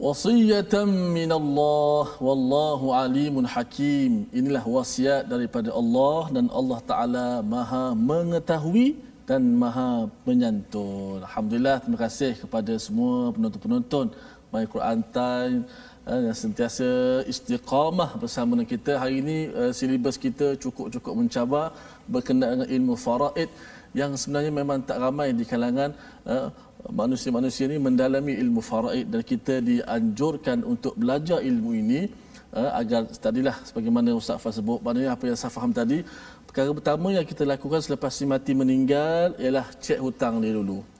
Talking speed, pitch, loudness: 130 wpm, 165 Hz, -25 LUFS